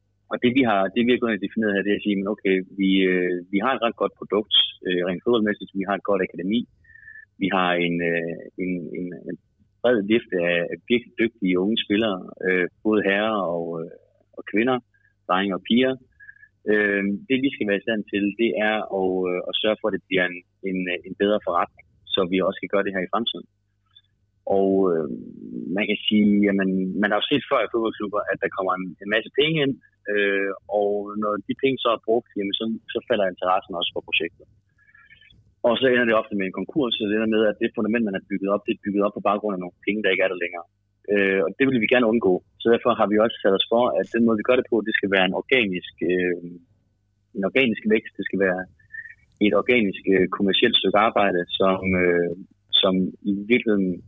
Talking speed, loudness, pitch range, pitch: 210 wpm, -22 LUFS, 95-110 Hz, 100 Hz